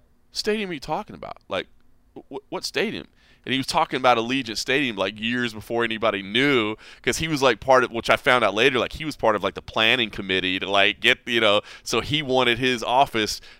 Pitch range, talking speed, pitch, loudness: 110-135 Hz, 225 wpm, 120 Hz, -22 LUFS